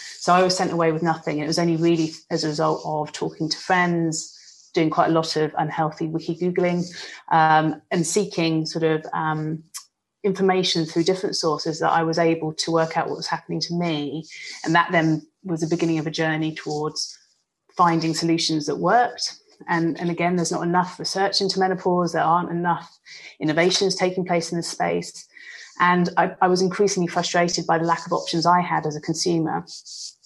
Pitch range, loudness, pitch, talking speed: 160-175 Hz, -22 LUFS, 165 Hz, 190 wpm